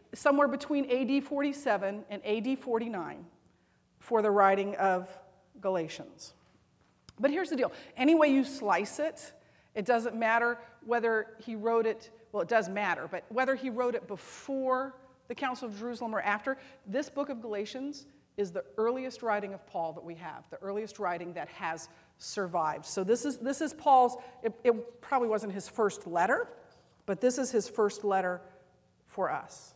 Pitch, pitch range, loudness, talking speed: 230 Hz, 205-260 Hz, -31 LUFS, 170 wpm